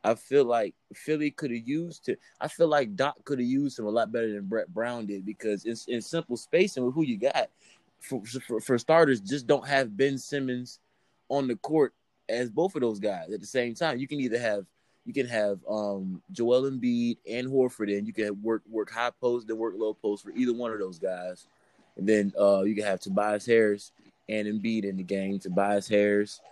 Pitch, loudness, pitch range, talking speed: 115 Hz, -28 LUFS, 105-130 Hz, 225 wpm